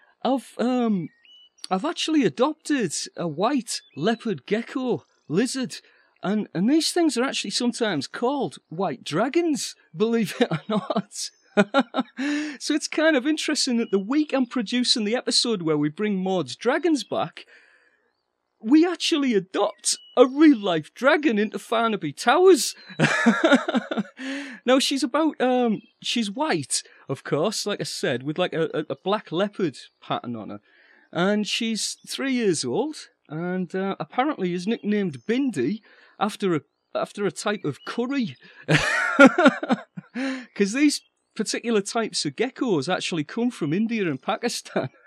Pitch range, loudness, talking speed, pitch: 195-275 Hz, -24 LUFS, 135 wpm, 230 Hz